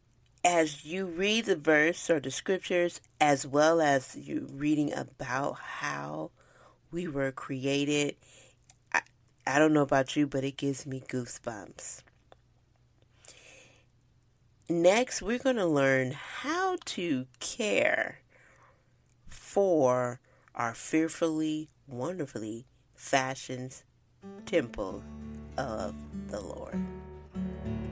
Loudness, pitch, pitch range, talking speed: -30 LUFS, 135 Hz, 120-165 Hz, 100 wpm